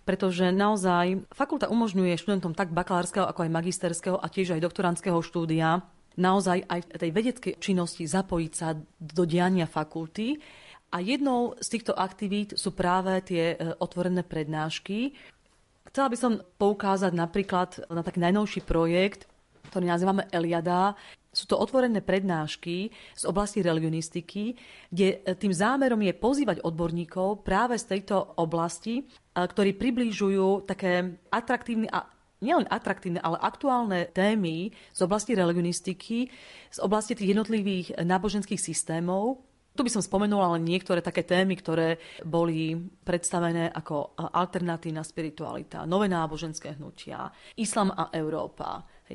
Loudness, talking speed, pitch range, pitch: -28 LUFS, 125 wpm, 170-205 Hz, 185 Hz